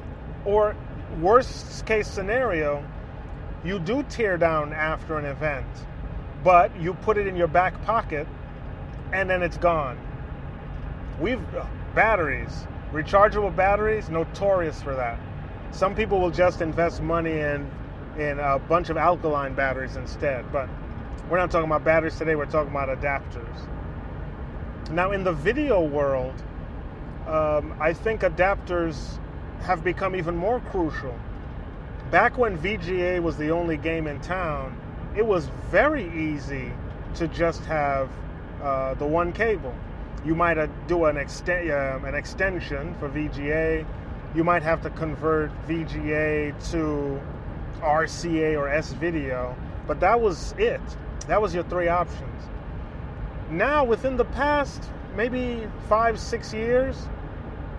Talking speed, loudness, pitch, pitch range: 135 wpm, -25 LUFS, 160 Hz, 140-180 Hz